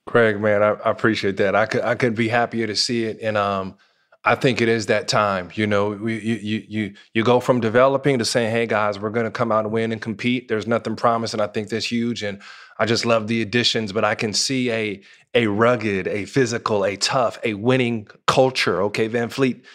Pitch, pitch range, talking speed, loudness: 115 Hz, 105-120 Hz, 230 wpm, -20 LUFS